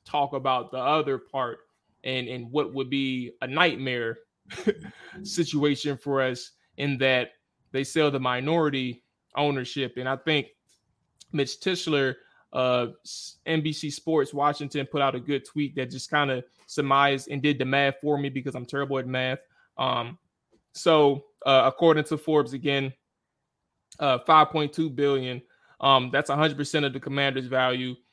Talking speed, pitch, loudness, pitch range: 145 wpm, 140 Hz, -26 LUFS, 130-150 Hz